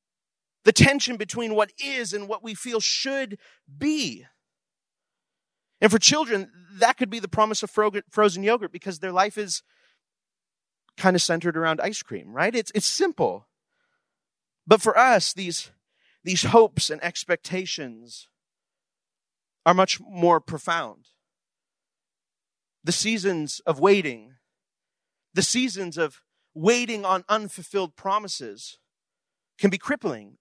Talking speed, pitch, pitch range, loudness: 125 wpm, 200 Hz, 175-225 Hz, -23 LUFS